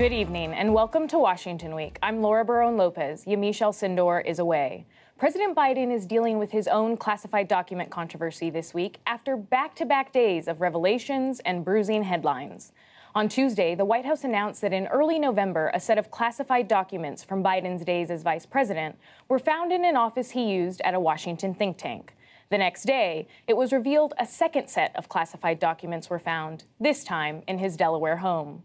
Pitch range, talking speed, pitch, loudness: 175-245 Hz, 180 wpm, 205 Hz, -26 LUFS